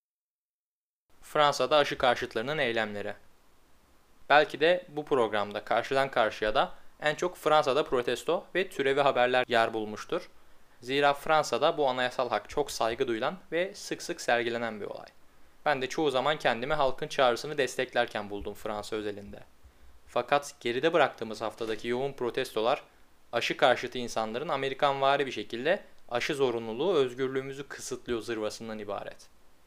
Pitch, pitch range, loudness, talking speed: 120 Hz, 105-140 Hz, -29 LUFS, 130 wpm